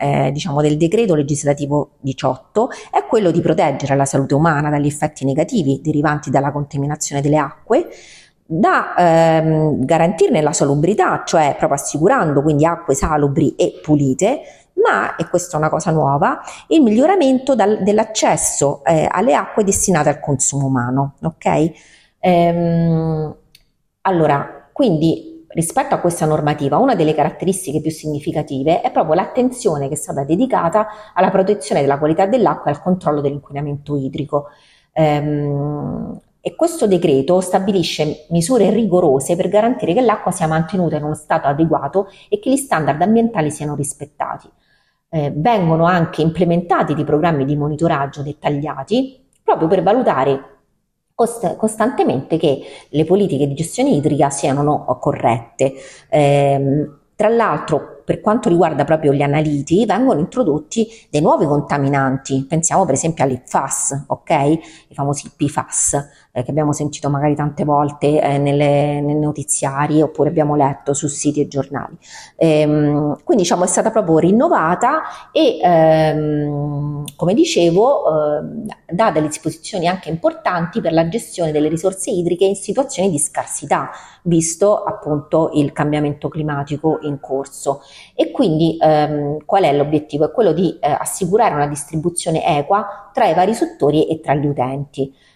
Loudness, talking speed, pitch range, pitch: -16 LUFS, 140 wpm, 145-180 Hz, 155 Hz